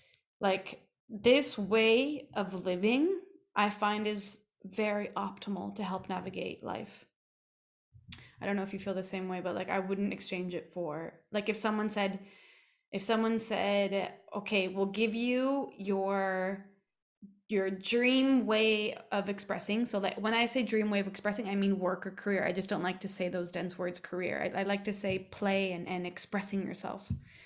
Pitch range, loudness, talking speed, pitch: 190-220 Hz, -33 LUFS, 175 wpm, 200 Hz